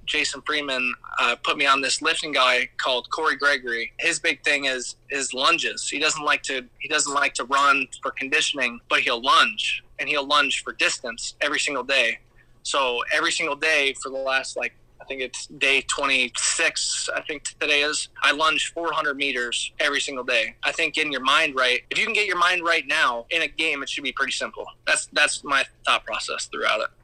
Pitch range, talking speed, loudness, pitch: 130-155 Hz, 205 wpm, -22 LUFS, 140 Hz